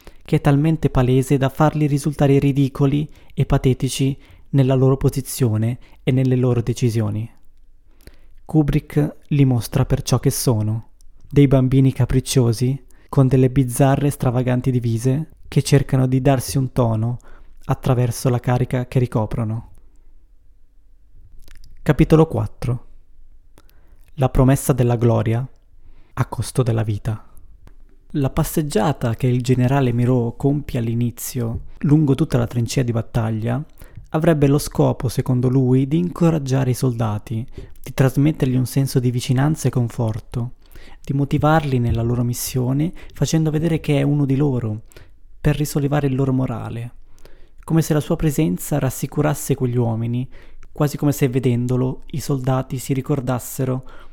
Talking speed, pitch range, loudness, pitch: 130 wpm, 115-140 Hz, -19 LUFS, 130 Hz